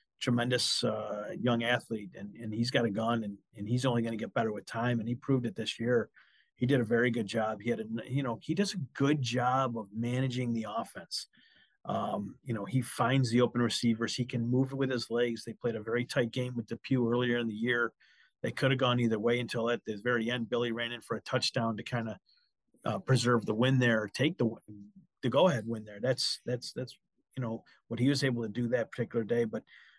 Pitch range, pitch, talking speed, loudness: 115-125 Hz, 120 Hz, 240 wpm, -32 LUFS